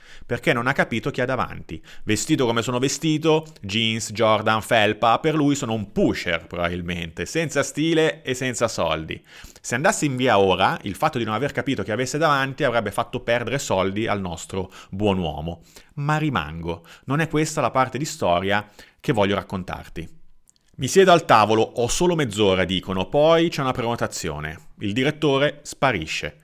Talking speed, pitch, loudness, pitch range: 170 wpm, 115 Hz, -22 LUFS, 95-145 Hz